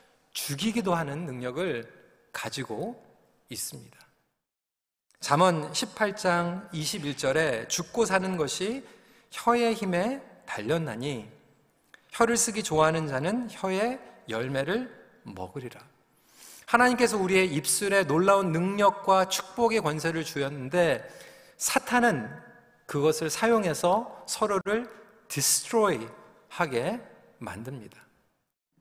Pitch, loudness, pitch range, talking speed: 190 Hz, -27 LUFS, 155-225 Hz, 220 characters per minute